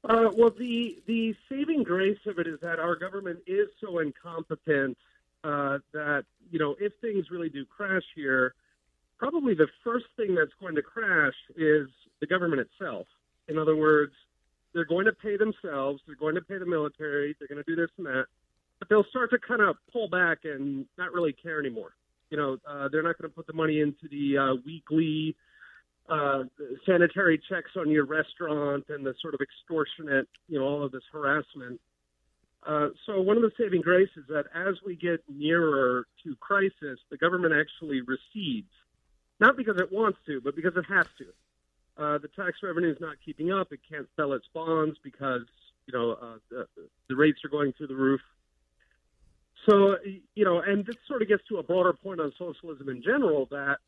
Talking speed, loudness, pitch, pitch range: 190 wpm, -28 LUFS, 155 Hz, 140-190 Hz